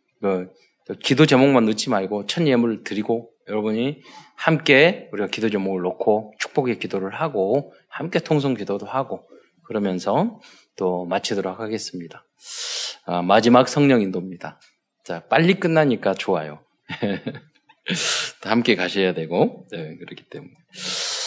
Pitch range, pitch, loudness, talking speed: 95-135 Hz, 110 Hz, -21 LUFS, 280 characters per minute